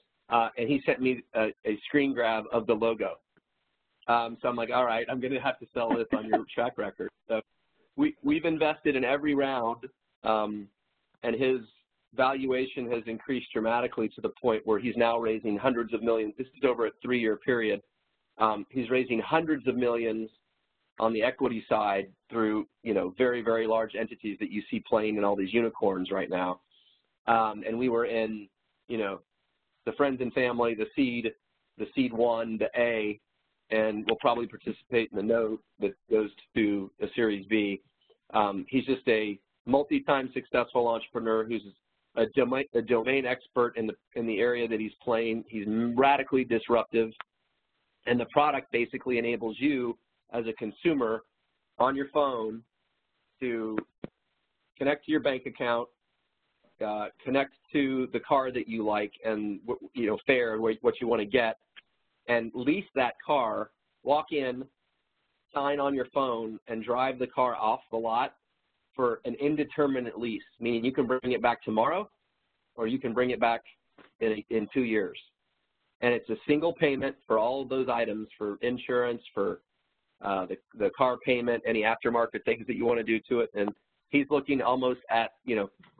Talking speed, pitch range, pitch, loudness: 175 wpm, 110-130 Hz, 115 Hz, -29 LUFS